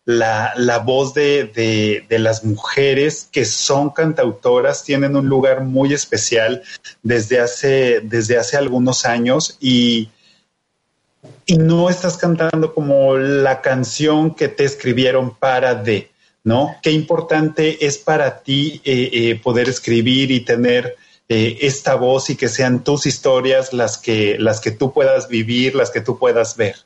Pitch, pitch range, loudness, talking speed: 130 Hz, 120-145 Hz, -16 LUFS, 150 wpm